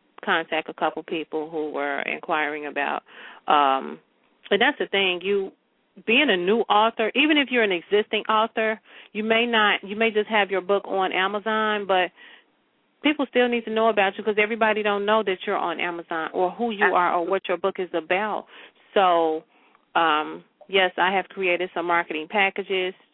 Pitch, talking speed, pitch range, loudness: 195 Hz, 180 wpm, 175-220 Hz, -23 LUFS